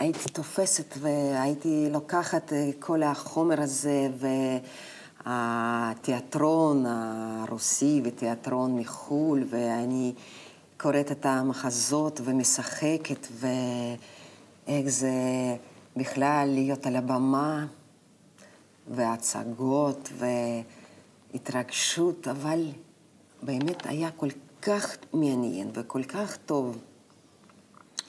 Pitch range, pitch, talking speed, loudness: 125-150 Hz, 135 Hz, 70 wpm, -28 LUFS